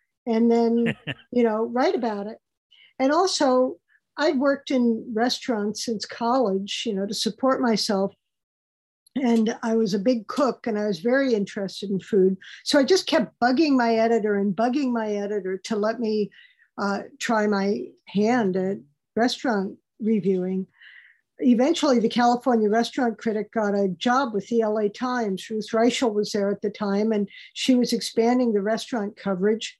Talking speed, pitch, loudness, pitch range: 160 wpm, 225 Hz, -23 LUFS, 205-245 Hz